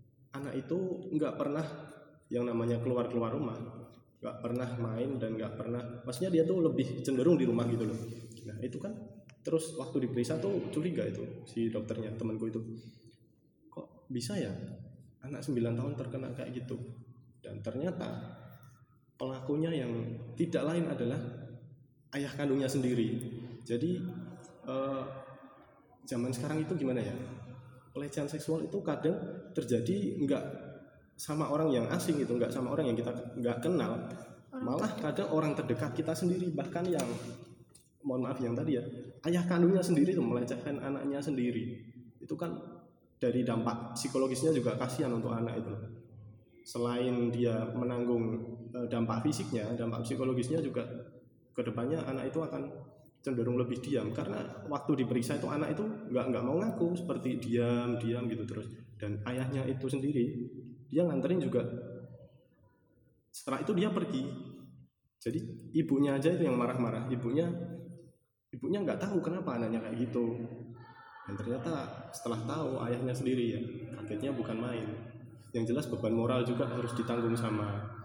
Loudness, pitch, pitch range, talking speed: -34 LUFS, 125 Hz, 115-140 Hz, 140 wpm